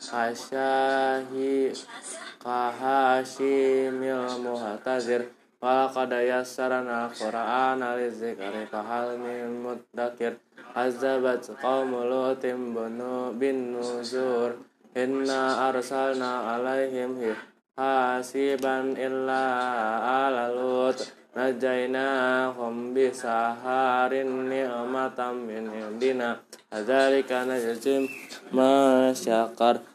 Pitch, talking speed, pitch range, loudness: 125 Hz, 55 wpm, 120-130 Hz, -27 LUFS